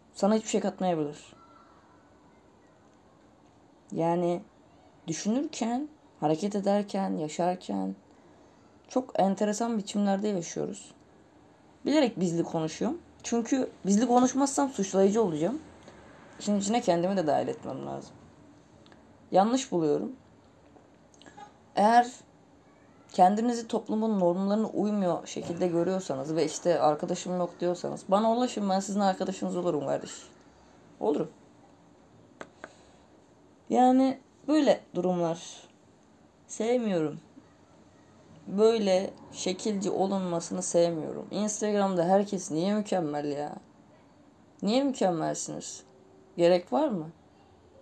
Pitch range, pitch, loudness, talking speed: 170-220 Hz, 190 Hz, -28 LUFS, 85 wpm